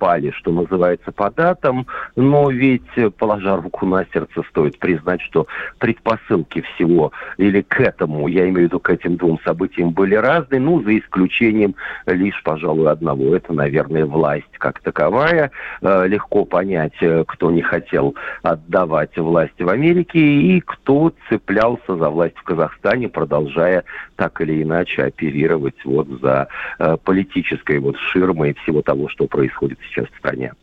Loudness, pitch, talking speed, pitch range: -17 LUFS, 95 Hz, 145 wpm, 85-120 Hz